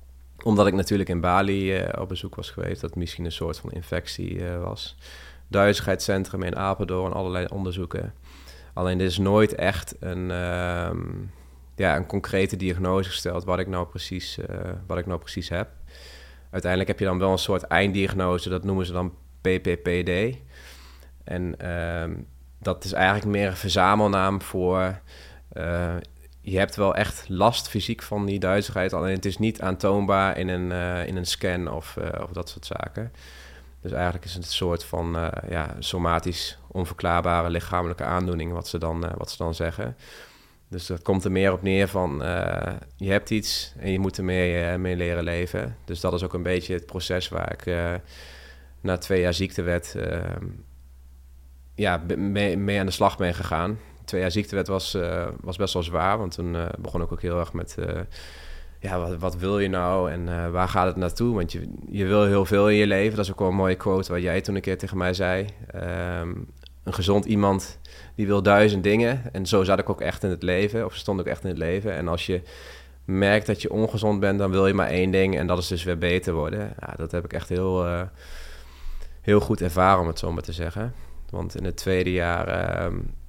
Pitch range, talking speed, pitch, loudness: 85-95 Hz, 205 wpm, 90 Hz, -25 LUFS